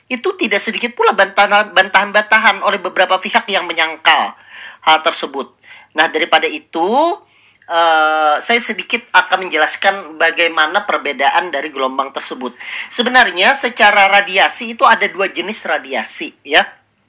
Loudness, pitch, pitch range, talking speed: -13 LUFS, 190 Hz, 160-220 Hz, 125 wpm